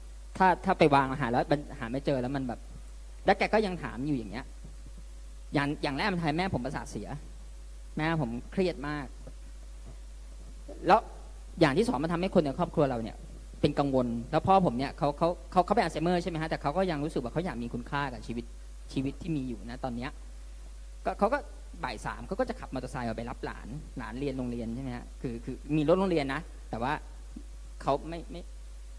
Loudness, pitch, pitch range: -31 LUFS, 135 Hz, 110-160 Hz